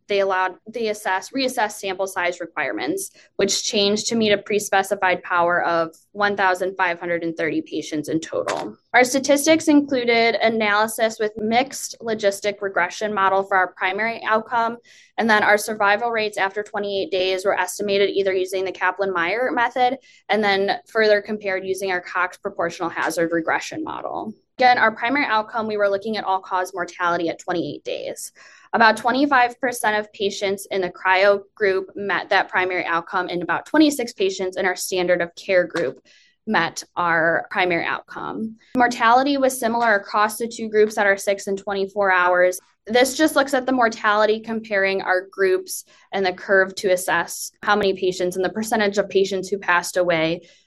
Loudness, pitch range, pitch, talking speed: -20 LUFS, 185-225 Hz, 200 Hz, 165 wpm